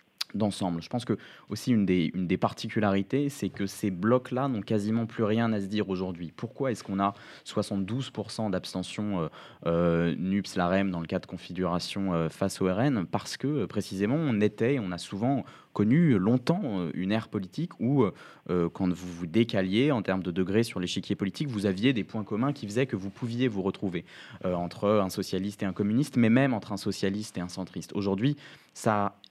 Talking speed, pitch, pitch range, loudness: 195 wpm, 100 Hz, 95-115 Hz, -29 LUFS